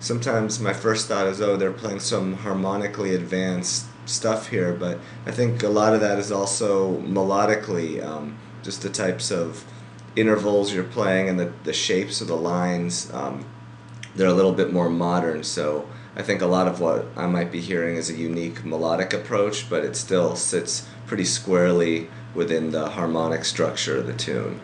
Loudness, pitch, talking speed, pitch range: -23 LUFS, 90 Hz, 180 wpm, 80-100 Hz